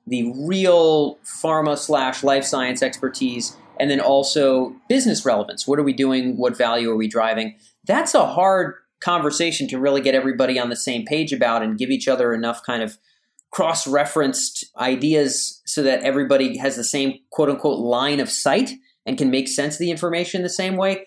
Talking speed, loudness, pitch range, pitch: 185 wpm, -20 LUFS, 125-155 Hz, 135 Hz